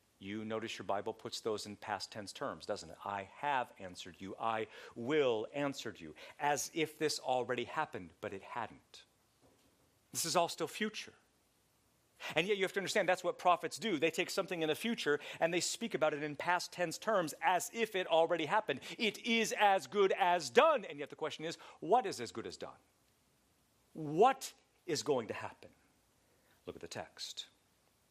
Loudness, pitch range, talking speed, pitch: -36 LUFS, 120-185 Hz, 190 wpm, 160 Hz